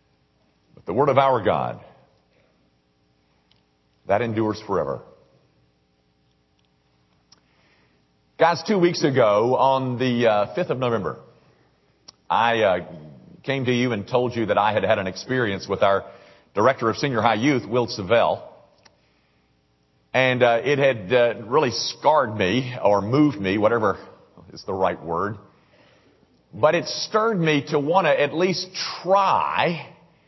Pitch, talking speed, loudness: 110 Hz, 135 wpm, -21 LUFS